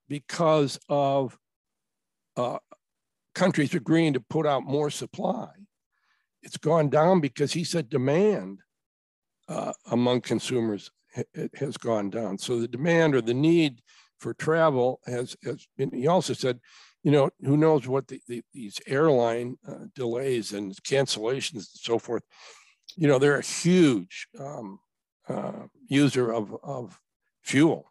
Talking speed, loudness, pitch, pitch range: 140 wpm, -26 LUFS, 140 Hz, 120-160 Hz